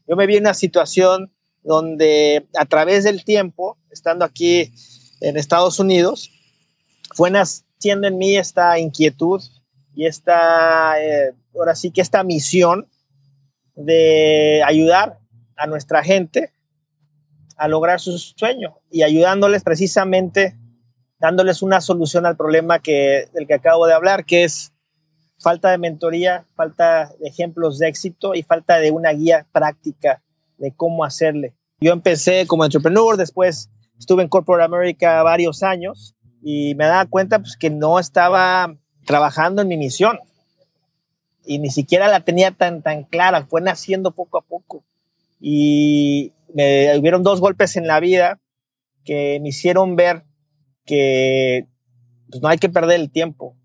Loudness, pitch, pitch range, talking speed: -16 LUFS, 165 Hz, 150-180 Hz, 145 wpm